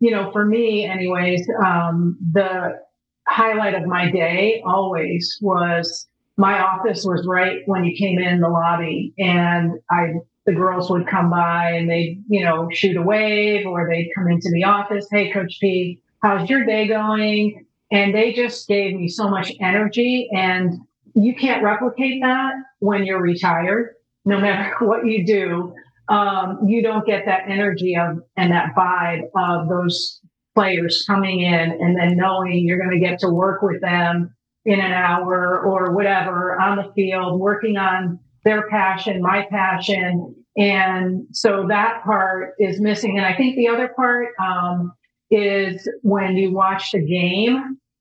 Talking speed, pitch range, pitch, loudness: 160 wpm, 180-210 Hz, 190 Hz, -19 LUFS